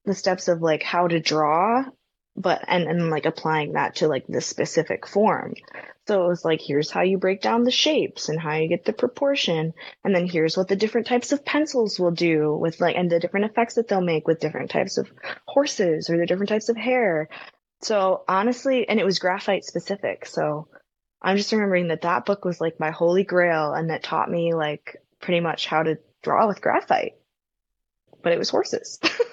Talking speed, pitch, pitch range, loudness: 205 wpm, 180 Hz, 160-215 Hz, -23 LUFS